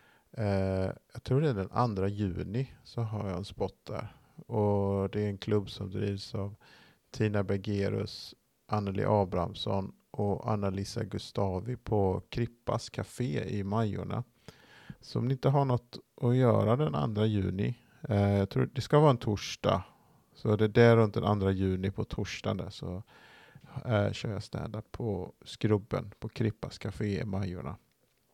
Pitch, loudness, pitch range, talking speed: 105 Hz, -31 LUFS, 100-120 Hz, 160 wpm